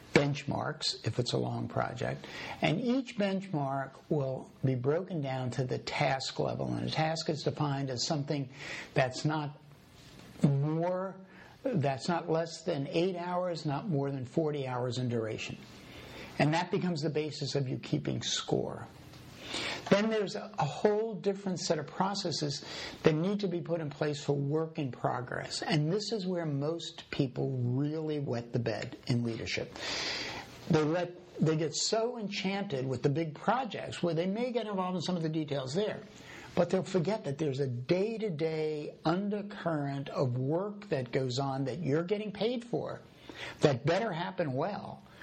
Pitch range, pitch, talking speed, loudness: 140-180 Hz, 160 Hz, 165 wpm, -33 LUFS